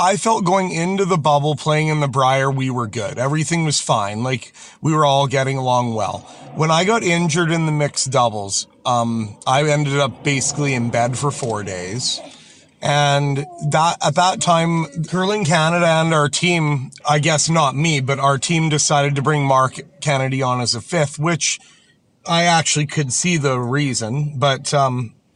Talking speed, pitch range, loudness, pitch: 180 wpm, 130-160 Hz, -18 LUFS, 145 Hz